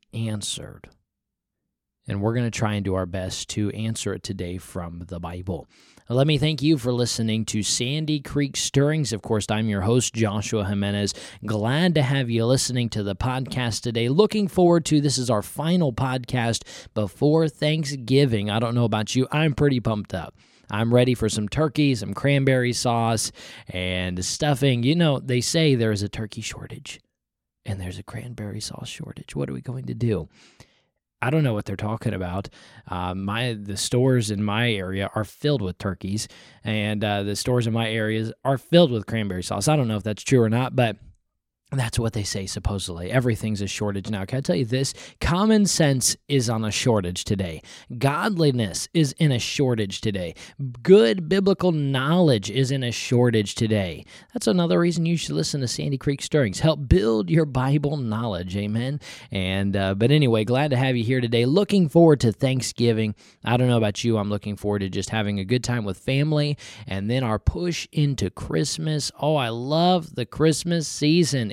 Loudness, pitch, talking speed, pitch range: -23 LUFS, 120 Hz, 190 wpm, 105-140 Hz